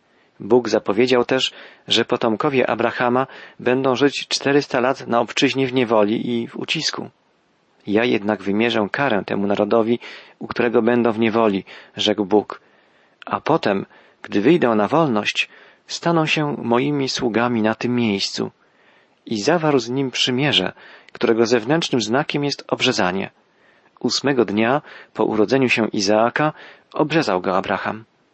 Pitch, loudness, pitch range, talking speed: 120 Hz, -19 LUFS, 110-130 Hz, 130 wpm